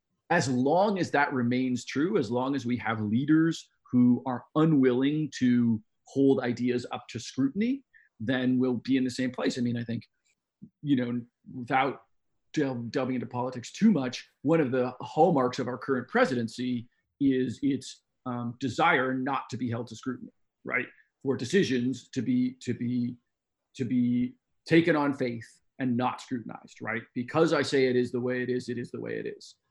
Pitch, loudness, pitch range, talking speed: 125 Hz, -28 LUFS, 125-135 Hz, 180 wpm